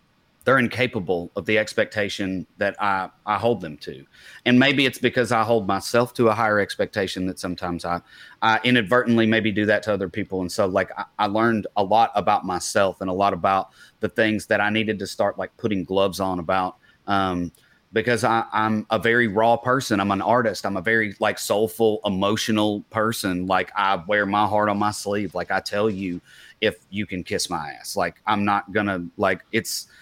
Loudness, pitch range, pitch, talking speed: -22 LUFS, 95-110 Hz, 105 Hz, 200 wpm